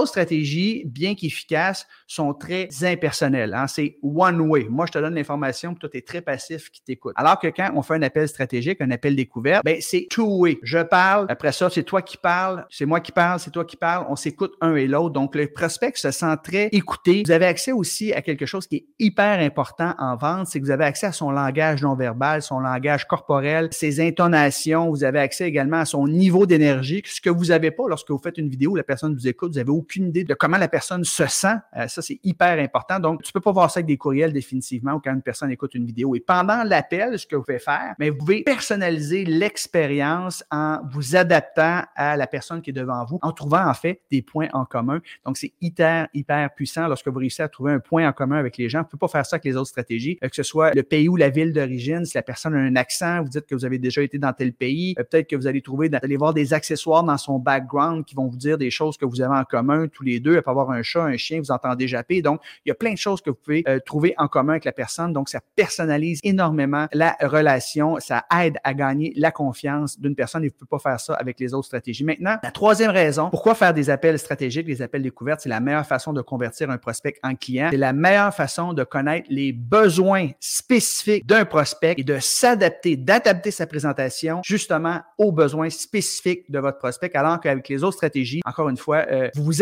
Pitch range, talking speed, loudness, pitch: 140-170 Hz, 245 wpm, -21 LUFS, 155 Hz